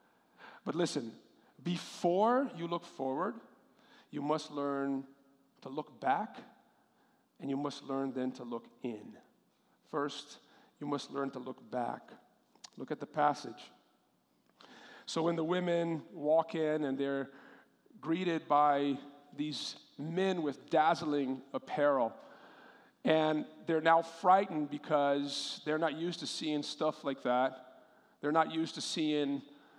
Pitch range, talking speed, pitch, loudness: 140-165 Hz, 130 wpm, 150 Hz, -34 LUFS